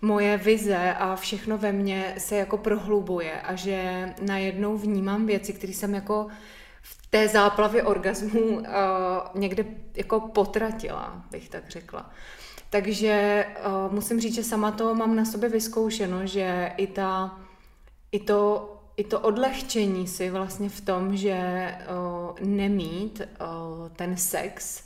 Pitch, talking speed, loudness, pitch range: 200 Hz, 140 wpm, -26 LUFS, 190-215 Hz